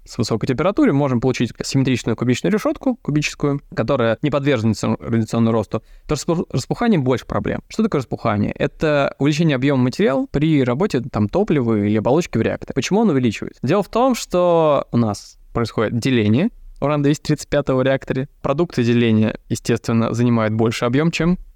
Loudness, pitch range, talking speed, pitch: -19 LUFS, 115-155 Hz, 155 wpm, 135 Hz